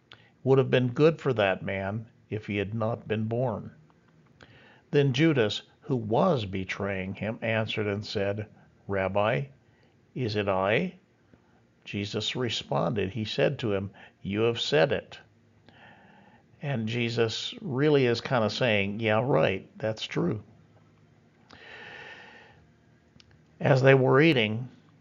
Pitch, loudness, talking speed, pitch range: 115 Hz, -27 LUFS, 120 wpm, 105-135 Hz